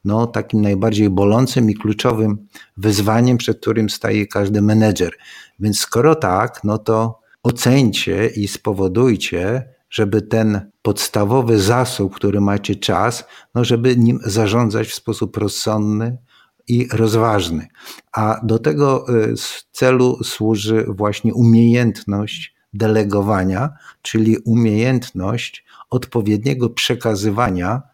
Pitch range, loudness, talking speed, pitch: 105-120 Hz, -17 LUFS, 105 wpm, 110 Hz